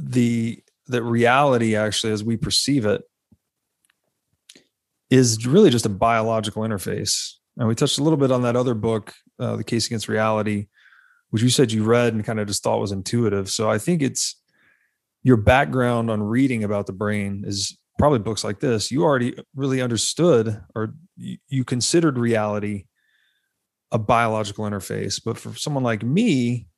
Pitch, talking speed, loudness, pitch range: 115 Hz, 165 wpm, -21 LUFS, 110-125 Hz